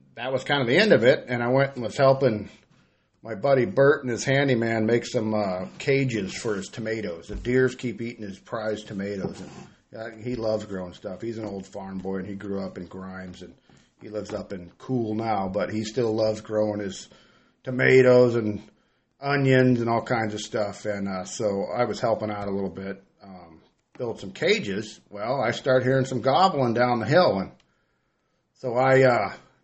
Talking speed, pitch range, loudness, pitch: 200 wpm, 100-125 Hz, -24 LUFS, 110 Hz